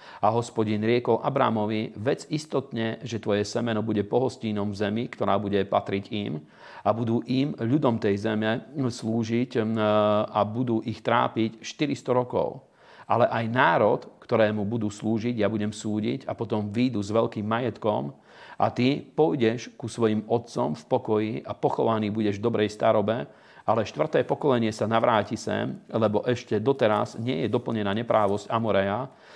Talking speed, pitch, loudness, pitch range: 150 wpm, 110 Hz, -26 LUFS, 105-120 Hz